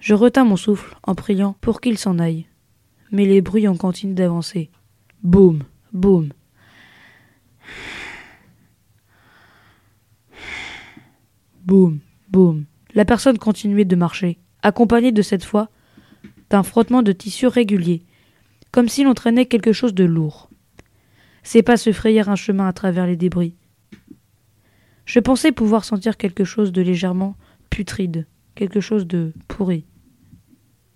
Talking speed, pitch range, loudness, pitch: 125 wpm, 160-215 Hz, -18 LUFS, 190 Hz